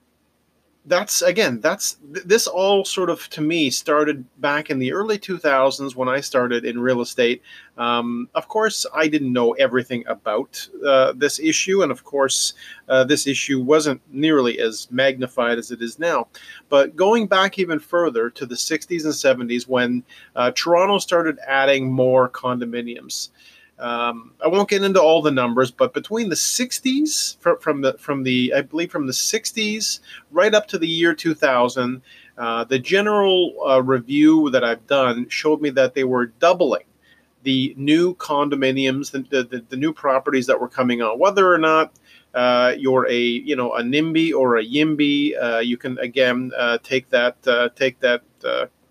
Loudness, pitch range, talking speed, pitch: -19 LUFS, 125-165 Hz, 180 wpm, 140 Hz